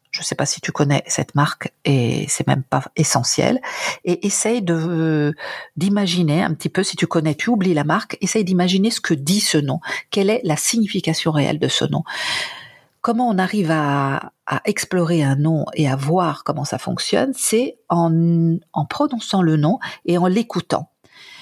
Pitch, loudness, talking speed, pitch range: 170 Hz, -19 LUFS, 185 wpm, 155-205 Hz